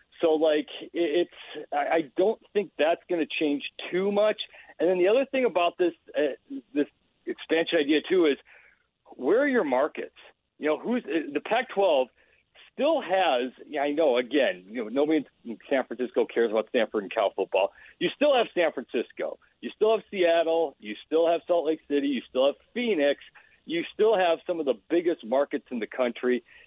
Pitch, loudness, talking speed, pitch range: 165 Hz, -26 LUFS, 185 wpm, 145-220 Hz